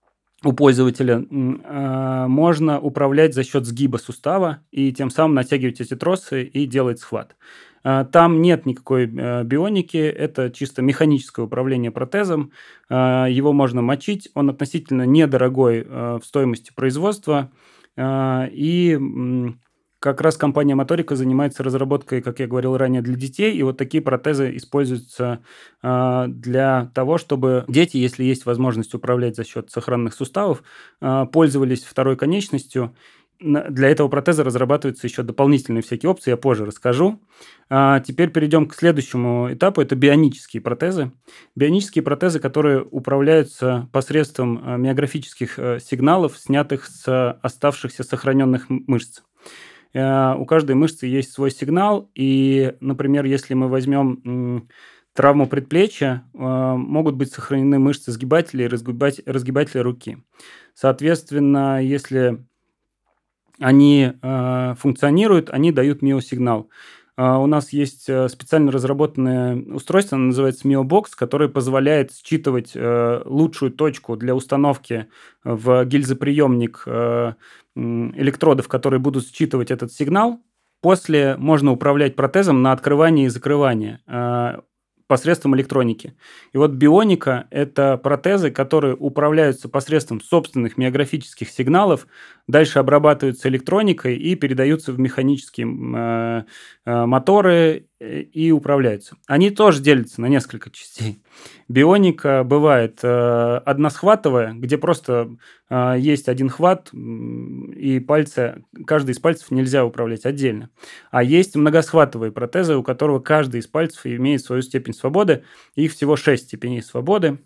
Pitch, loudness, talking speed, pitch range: 135 Hz, -18 LUFS, 115 wpm, 125-150 Hz